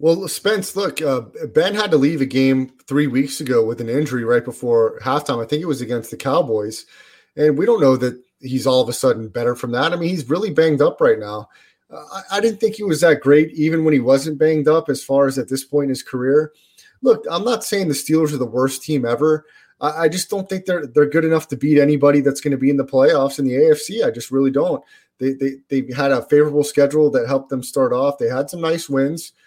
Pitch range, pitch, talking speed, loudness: 135-160 Hz, 145 Hz, 255 wpm, -18 LUFS